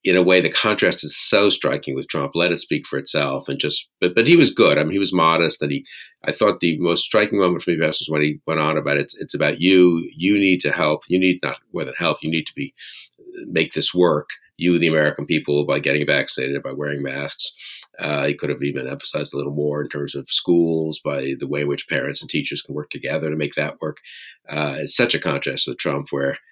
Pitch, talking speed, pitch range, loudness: 75 Hz, 250 wpm, 70-90 Hz, -19 LUFS